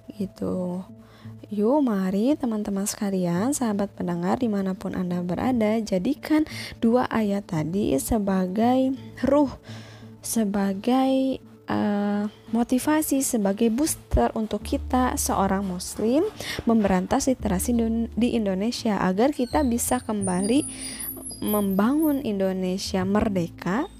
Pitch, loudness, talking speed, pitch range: 215 Hz, -24 LUFS, 90 wpm, 190-255 Hz